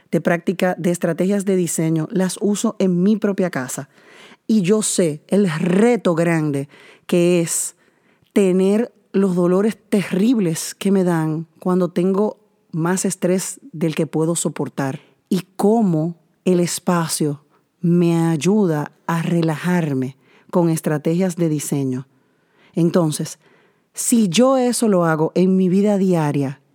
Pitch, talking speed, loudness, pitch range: 180 Hz, 130 wpm, -19 LUFS, 160-195 Hz